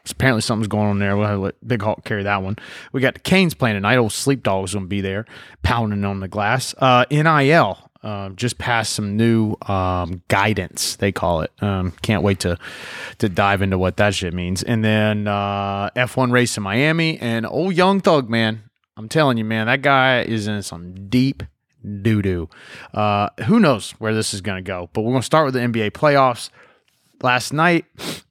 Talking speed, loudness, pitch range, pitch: 205 wpm, -19 LUFS, 100-125 Hz, 110 Hz